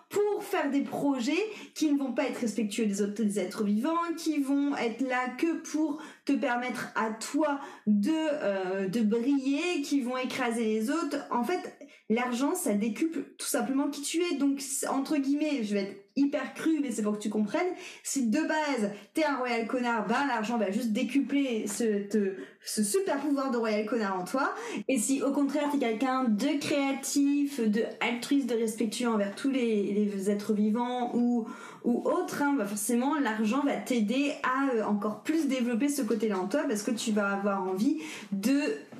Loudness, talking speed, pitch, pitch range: -29 LUFS, 190 wpm, 255 Hz, 220-290 Hz